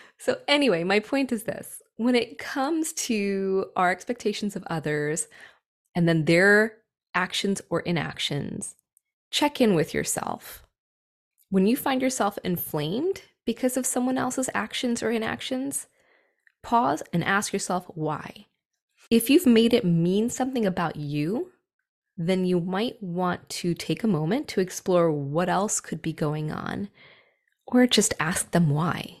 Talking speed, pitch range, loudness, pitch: 145 wpm, 175-245 Hz, -25 LUFS, 200 Hz